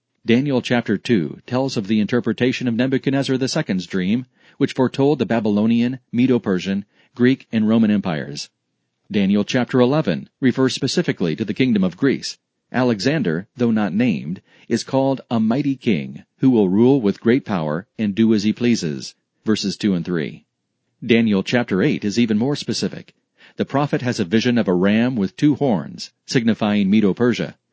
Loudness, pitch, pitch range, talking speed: -19 LUFS, 120 Hz, 105-135 Hz, 160 wpm